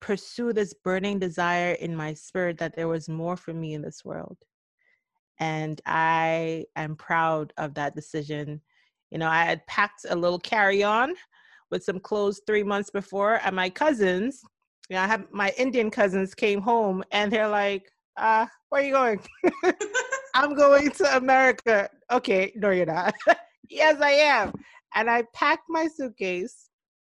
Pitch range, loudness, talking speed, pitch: 175-260 Hz, -25 LUFS, 160 wpm, 205 Hz